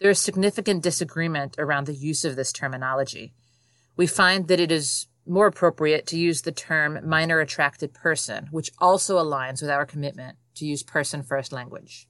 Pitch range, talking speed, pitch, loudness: 135-170 Hz, 175 wpm, 150 Hz, -23 LUFS